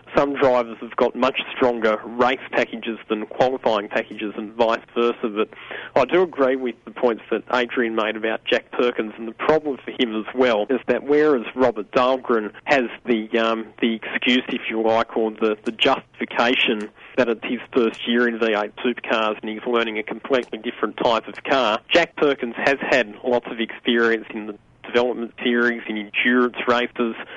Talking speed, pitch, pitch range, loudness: 180 wpm, 120 Hz, 110-125 Hz, -21 LUFS